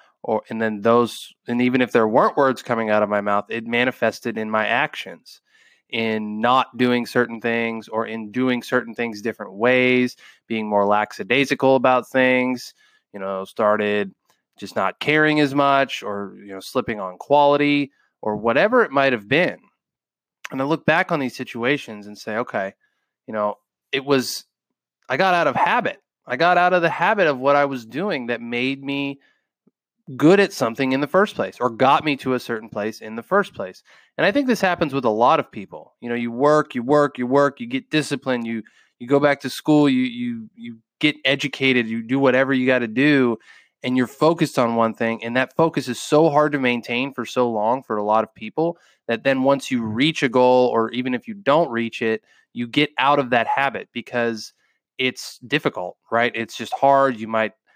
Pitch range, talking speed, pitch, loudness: 115-145 Hz, 205 wpm, 125 Hz, -20 LUFS